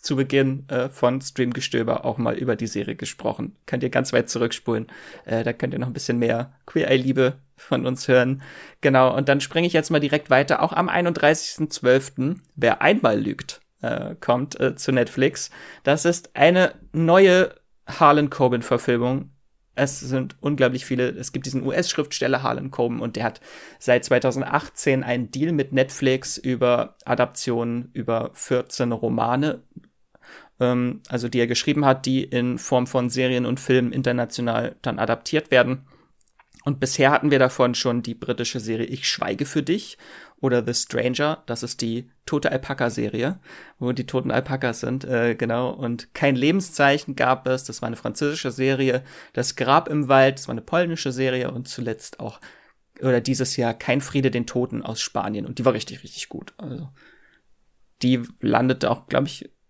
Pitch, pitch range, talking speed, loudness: 130 Hz, 125-140 Hz, 170 wpm, -22 LUFS